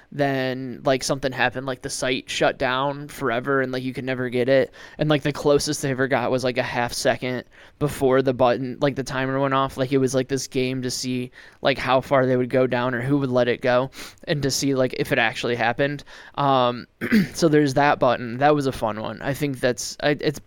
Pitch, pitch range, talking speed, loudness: 130 Hz, 125-140 Hz, 240 wpm, -22 LUFS